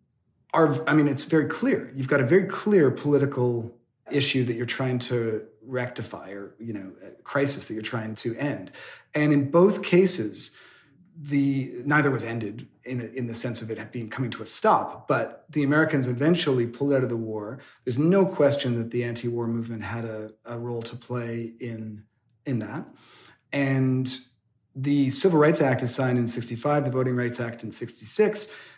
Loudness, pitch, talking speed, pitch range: -24 LUFS, 125 Hz, 185 wpm, 115-145 Hz